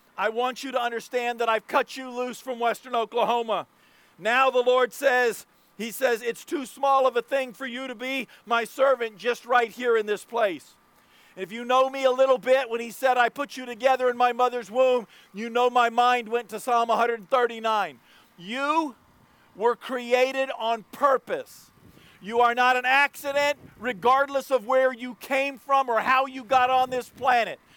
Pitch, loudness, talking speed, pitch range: 250 Hz, -24 LUFS, 185 wpm, 235-265 Hz